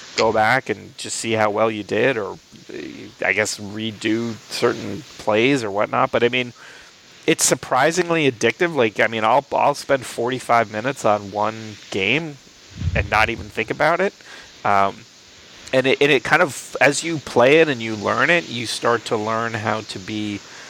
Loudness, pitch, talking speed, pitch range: -19 LUFS, 115 Hz, 180 wpm, 105-130 Hz